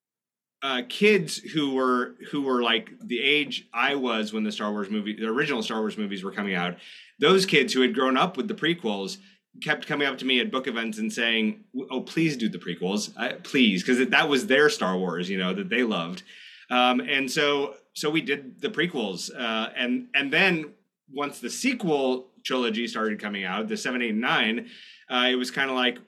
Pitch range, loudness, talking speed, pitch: 110-145 Hz, -25 LUFS, 205 wpm, 125 Hz